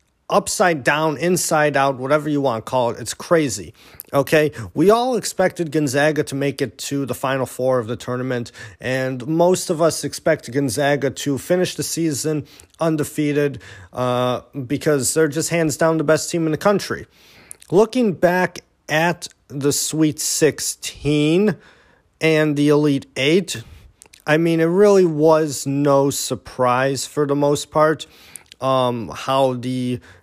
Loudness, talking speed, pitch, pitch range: -19 LUFS, 145 wpm, 145 Hz, 130-160 Hz